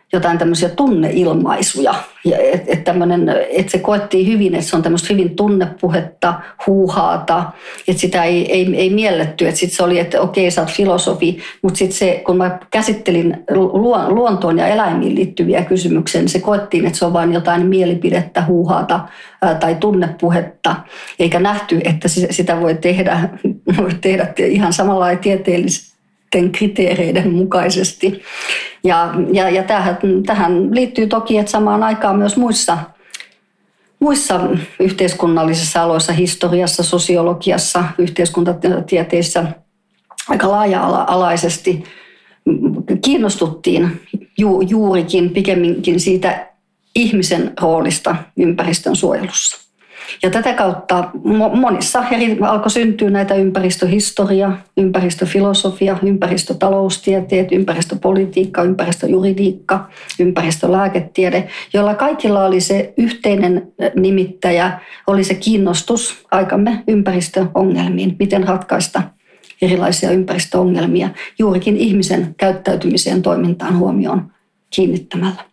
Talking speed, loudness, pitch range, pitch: 105 wpm, -15 LUFS, 175-195 Hz, 185 Hz